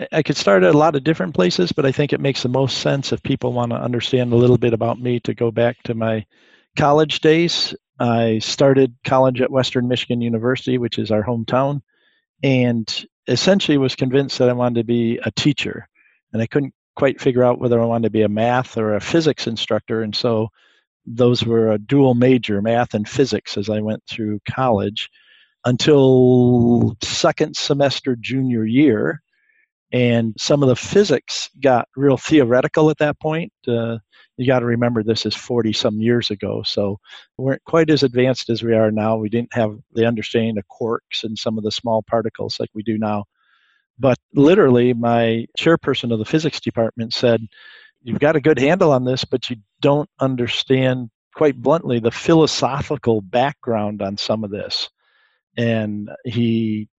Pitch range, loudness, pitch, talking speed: 115-140 Hz, -18 LUFS, 120 Hz, 180 wpm